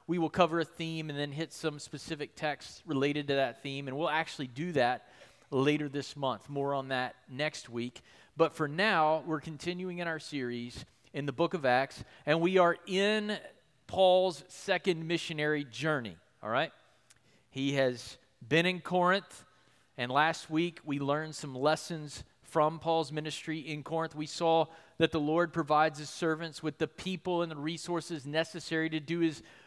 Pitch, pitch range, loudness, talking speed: 155 Hz, 140-165 Hz, -32 LUFS, 175 wpm